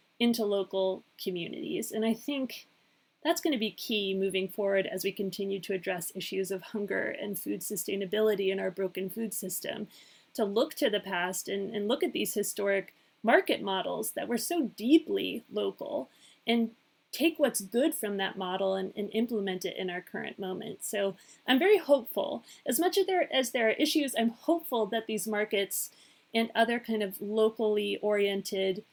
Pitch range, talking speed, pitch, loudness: 195-235 Hz, 175 wpm, 210 Hz, -31 LUFS